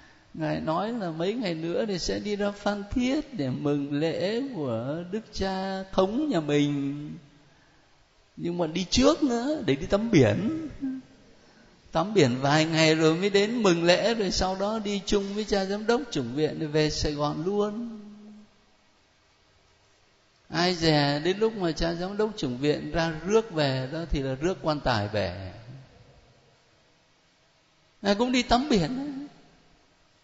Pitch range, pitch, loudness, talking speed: 145-210 Hz, 170 Hz, -26 LUFS, 160 wpm